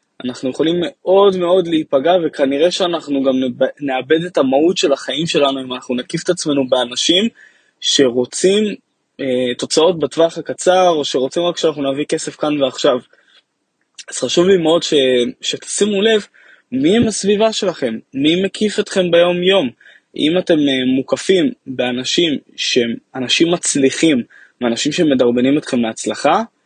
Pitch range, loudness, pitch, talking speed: 135-185 Hz, -16 LUFS, 160 Hz, 135 wpm